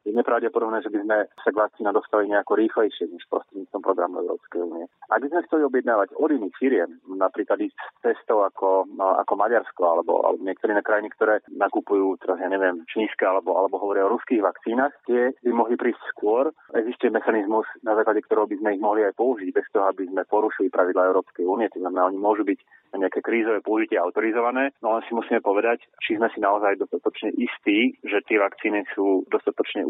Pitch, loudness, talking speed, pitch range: 110 Hz, -23 LUFS, 195 wpm, 95-125 Hz